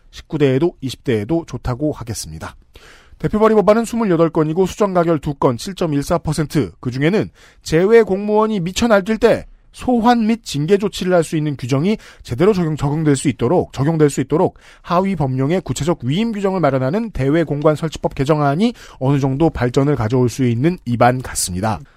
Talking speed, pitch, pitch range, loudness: 340 characters per minute, 155 Hz, 135-190 Hz, -17 LUFS